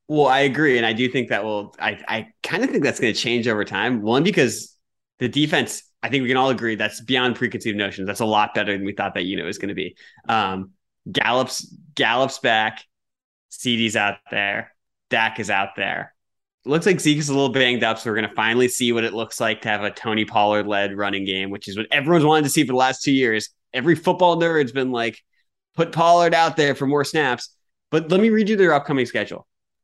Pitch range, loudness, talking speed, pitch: 110-145 Hz, -20 LUFS, 235 wpm, 125 Hz